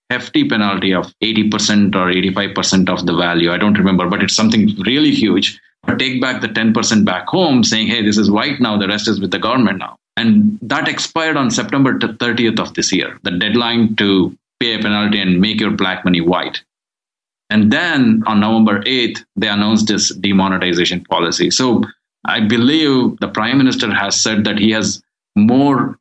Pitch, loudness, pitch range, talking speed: 105 Hz, -14 LUFS, 100-130 Hz, 185 wpm